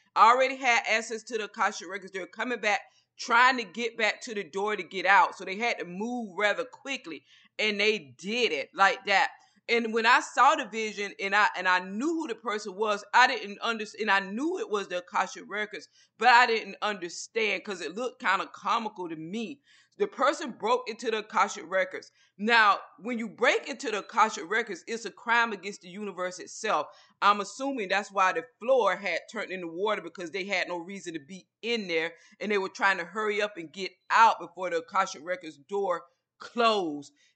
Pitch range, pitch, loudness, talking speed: 190-235 Hz, 210 Hz, -27 LUFS, 205 wpm